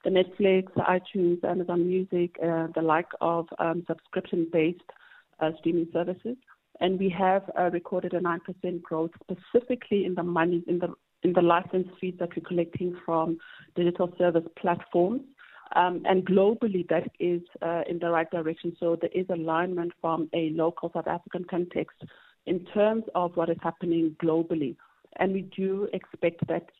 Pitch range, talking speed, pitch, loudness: 170-185 Hz, 165 wpm, 175 Hz, -28 LUFS